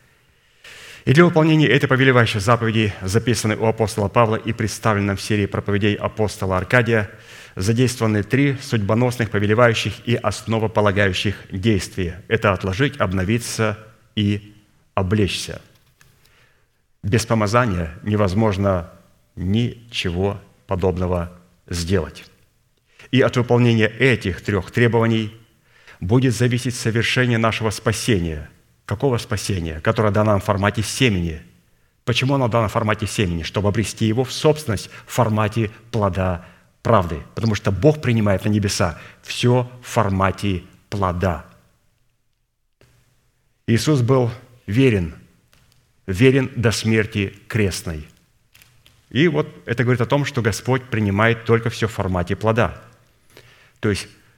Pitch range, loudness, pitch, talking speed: 100-120 Hz, -20 LUFS, 110 Hz, 115 wpm